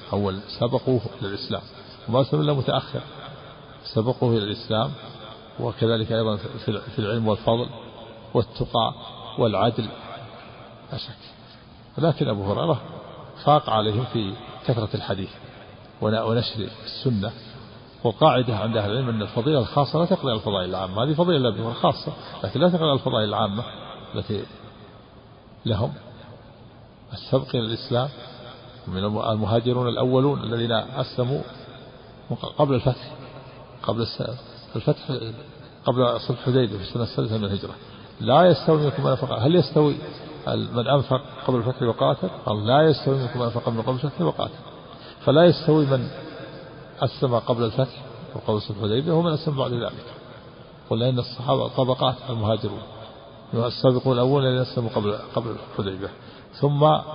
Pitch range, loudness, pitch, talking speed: 110-135 Hz, -23 LUFS, 125 Hz, 120 wpm